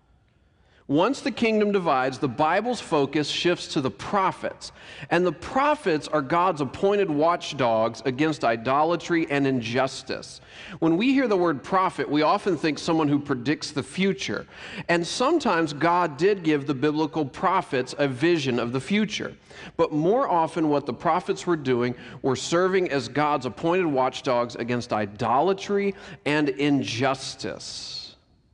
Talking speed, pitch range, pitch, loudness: 140 wpm, 135-175 Hz, 155 Hz, -24 LUFS